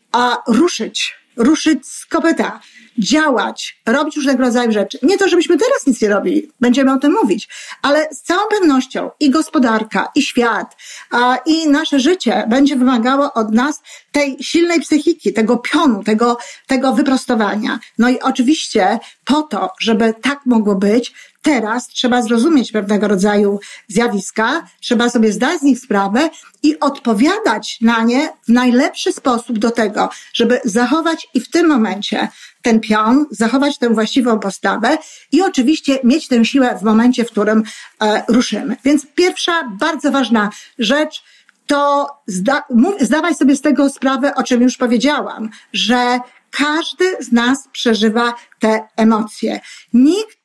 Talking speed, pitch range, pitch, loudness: 145 wpm, 230-295 Hz, 255 Hz, -15 LUFS